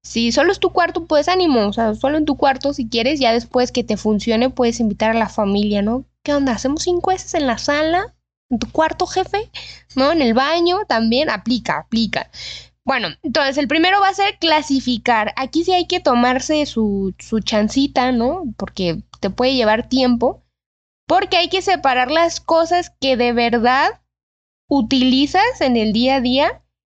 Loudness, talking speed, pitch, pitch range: -17 LUFS, 185 wpm, 260 Hz, 225-315 Hz